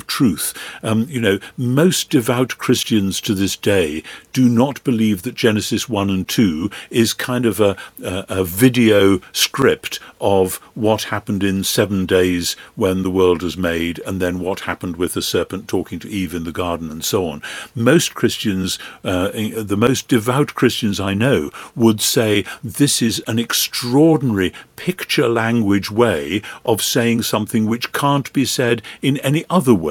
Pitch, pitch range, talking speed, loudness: 110 Hz, 95-125 Hz, 165 wpm, -18 LUFS